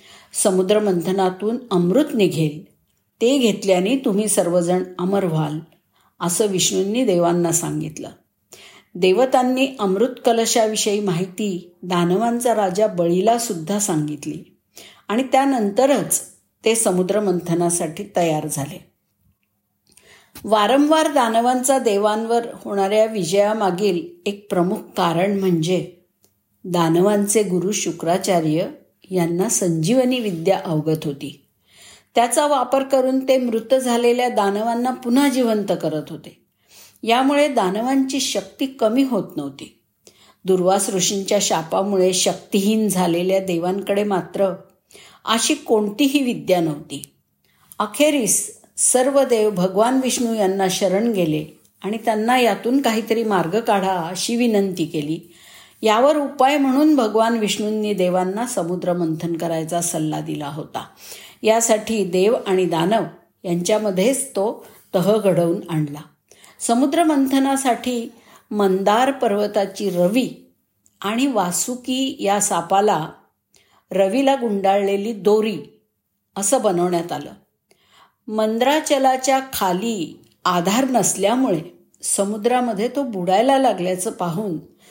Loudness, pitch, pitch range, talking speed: -19 LUFS, 200 Hz, 180-235 Hz, 95 wpm